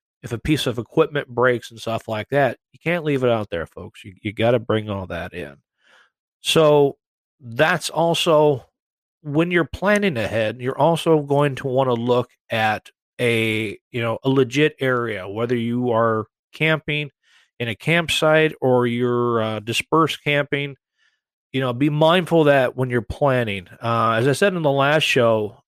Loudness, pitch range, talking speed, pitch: -20 LUFS, 115-150 Hz, 175 wpm, 130 Hz